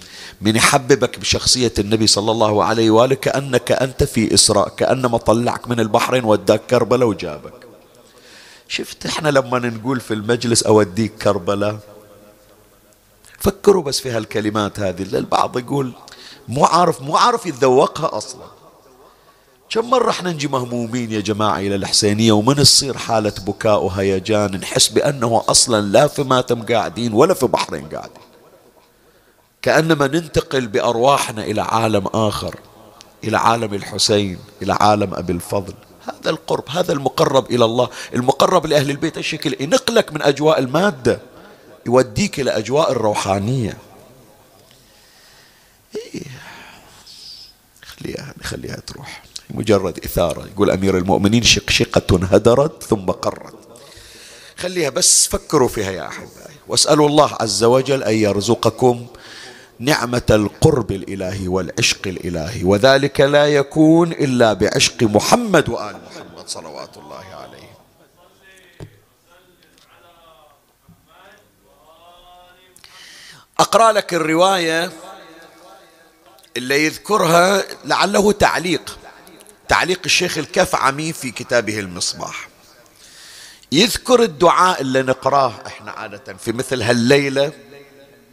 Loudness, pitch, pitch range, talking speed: -16 LUFS, 125 Hz, 105-150 Hz, 110 wpm